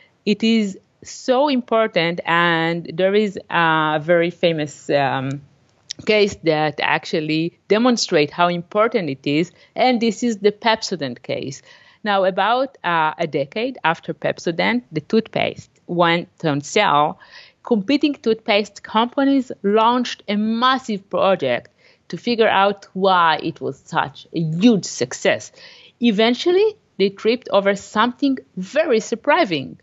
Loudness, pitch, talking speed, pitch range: -19 LUFS, 200 Hz, 125 wpm, 165-230 Hz